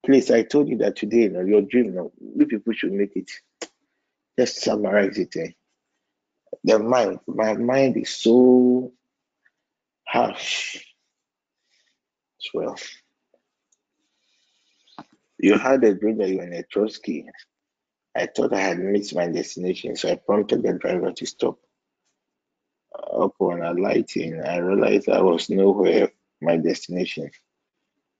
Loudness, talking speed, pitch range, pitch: -22 LUFS, 130 wpm, 95-125 Hz, 110 Hz